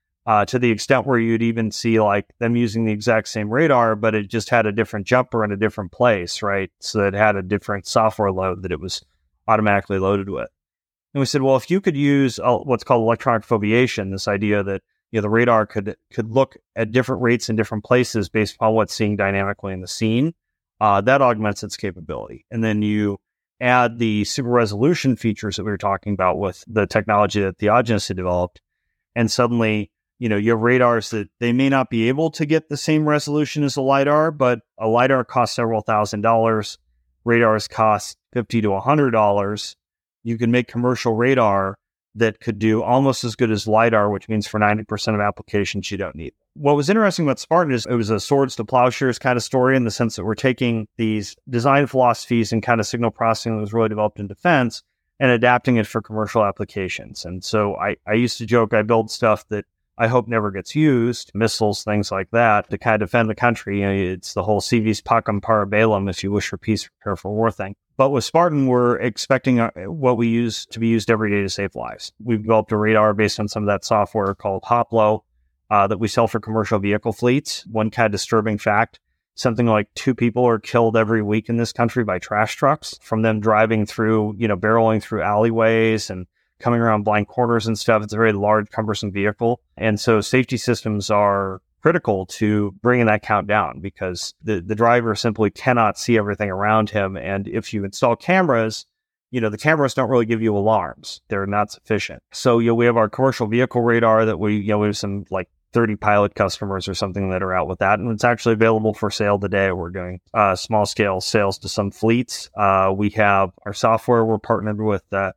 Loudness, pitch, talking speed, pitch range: -19 LUFS, 110 Hz, 215 wpm, 105-120 Hz